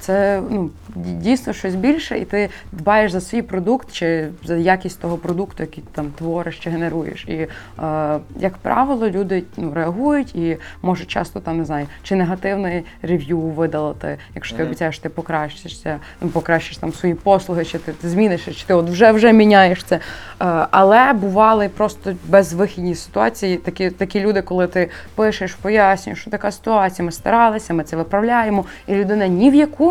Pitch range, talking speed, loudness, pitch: 165-205 Hz, 170 wpm, -18 LUFS, 185 Hz